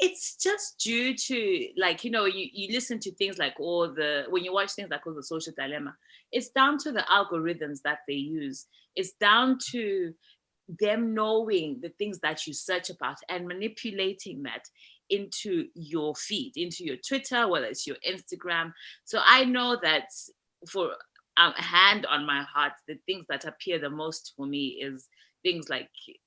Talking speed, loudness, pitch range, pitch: 180 wpm, -28 LUFS, 155-235 Hz, 185 Hz